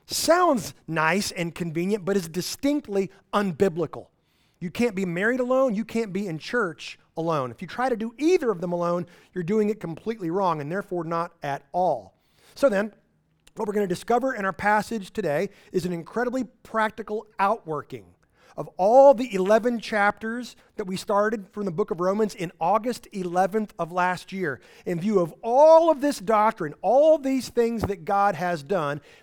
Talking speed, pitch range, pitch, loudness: 180 wpm, 180-225 Hz, 200 Hz, -24 LUFS